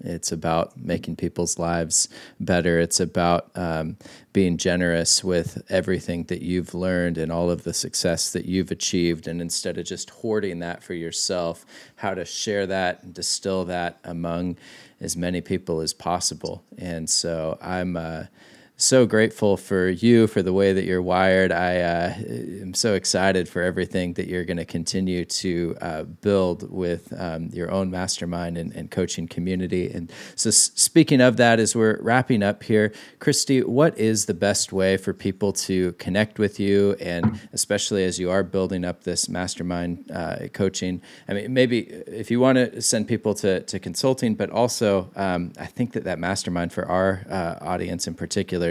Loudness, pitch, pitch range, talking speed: -23 LUFS, 90 Hz, 85-100 Hz, 175 wpm